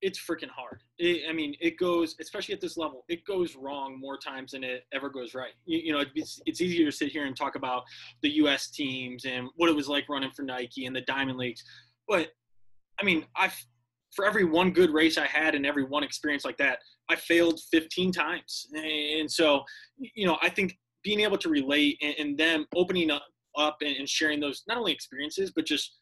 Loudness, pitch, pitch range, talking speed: -28 LUFS, 150 Hz, 135-170 Hz, 215 wpm